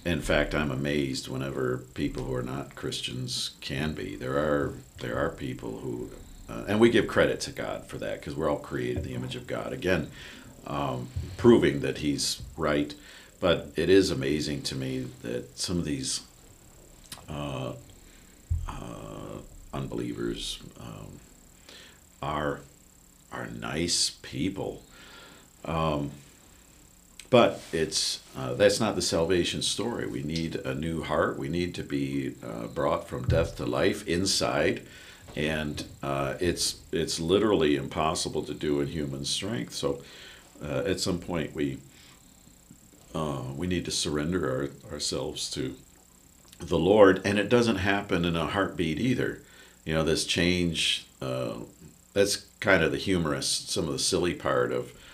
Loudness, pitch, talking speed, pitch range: -28 LUFS, 75 Hz, 150 wpm, 65-85 Hz